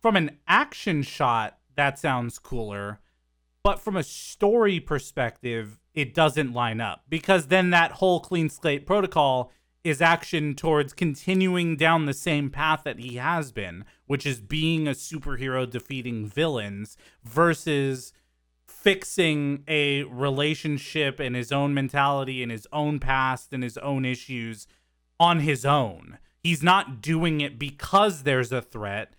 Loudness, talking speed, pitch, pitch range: -25 LUFS, 140 wpm, 140 Hz, 125-160 Hz